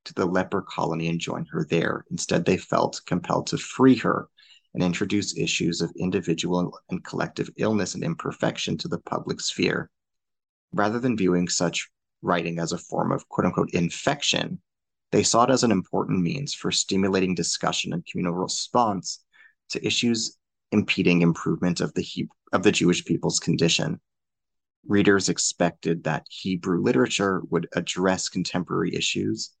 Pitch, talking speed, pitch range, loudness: 90 Hz, 150 wpm, 85-100 Hz, -25 LUFS